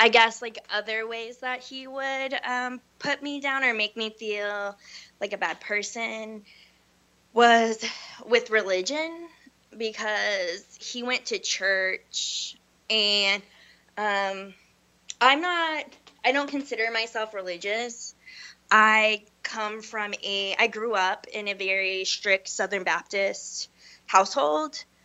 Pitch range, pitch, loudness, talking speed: 200-245 Hz, 220 Hz, -25 LUFS, 120 wpm